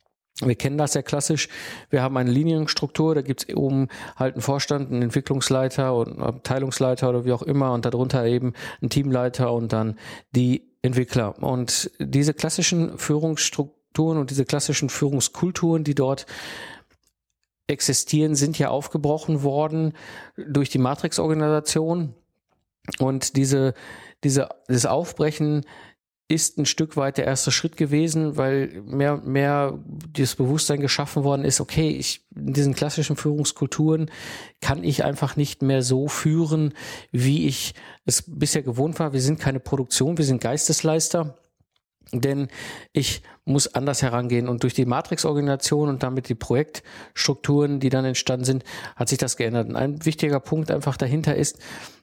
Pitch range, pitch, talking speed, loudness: 130-150 Hz, 140 Hz, 150 wpm, -23 LUFS